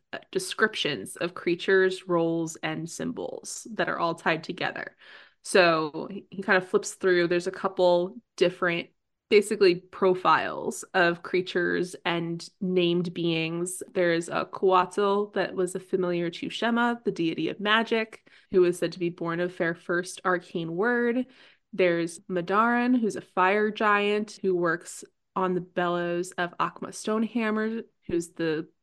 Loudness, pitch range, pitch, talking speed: -26 LUFS, 175-205 Hz, 185 Hz, 140 wpm